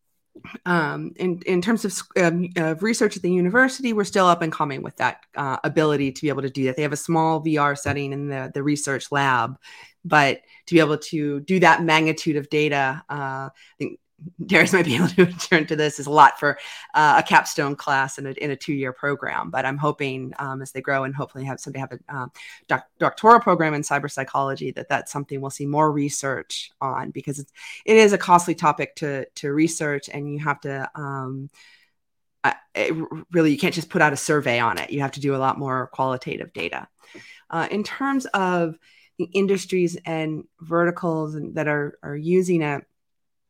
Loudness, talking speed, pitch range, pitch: -22 LUFS, 205 wpm, 140-170 Hz, 150 Hz